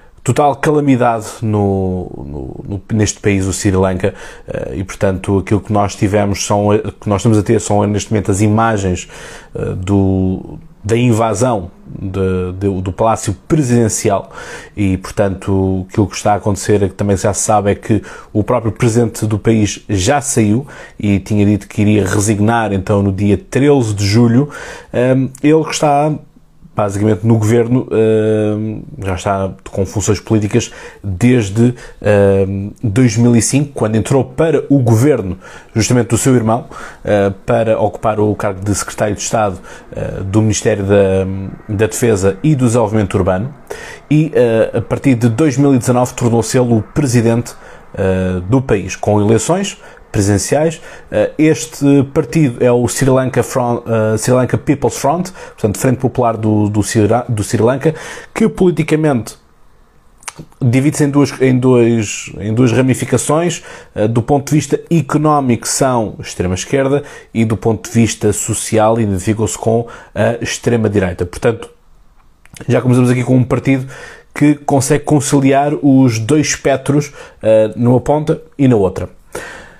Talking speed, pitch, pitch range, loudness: 140 wpm, 115 Hz, 105-130 Hz, -14 LUFS